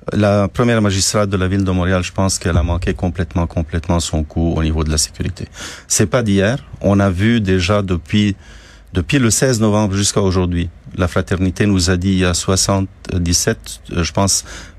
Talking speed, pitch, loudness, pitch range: 190 wpm, 95 Hz, -16 LUFS, 85-100 Hz